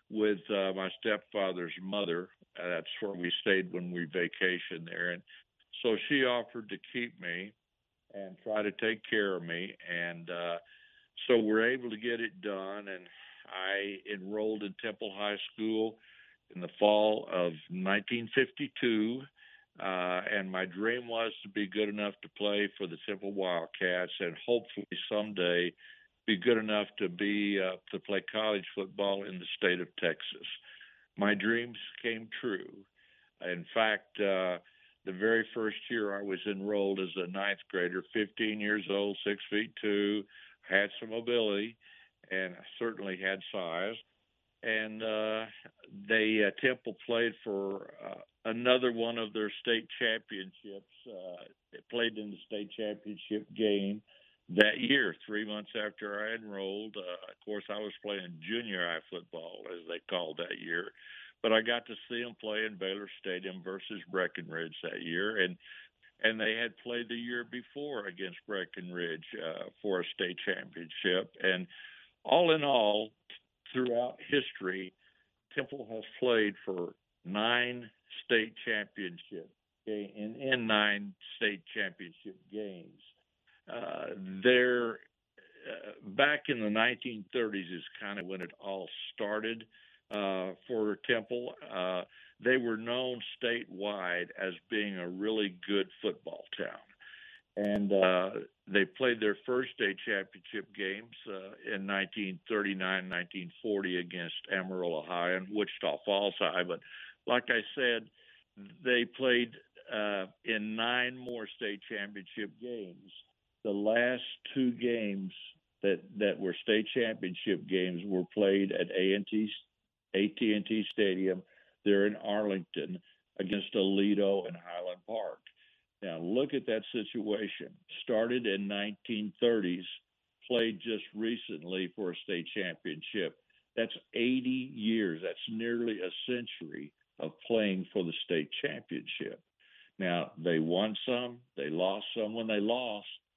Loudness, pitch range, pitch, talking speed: -34 LUFS, 95-115 Hz, 105 Hz, 140 wpm